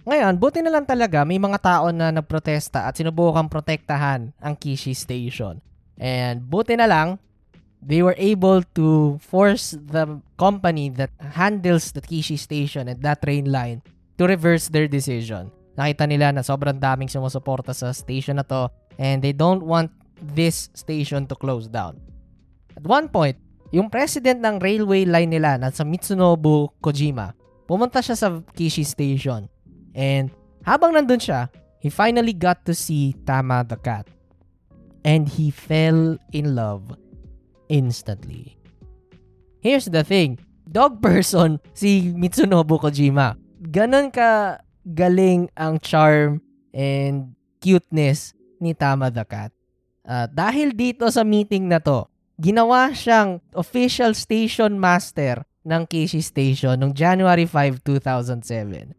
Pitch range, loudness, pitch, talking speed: 135-180 Hz, -20 LUFS, 155 Hz, 135 wpm